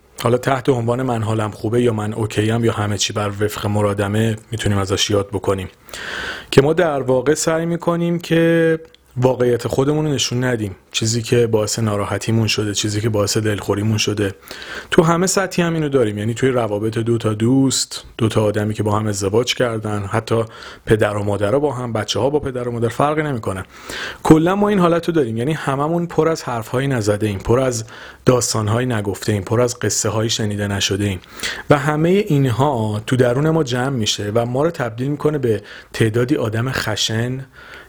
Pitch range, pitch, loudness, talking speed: 105-135 Hz, 115 Hz, -18 LUFS, 185 wpm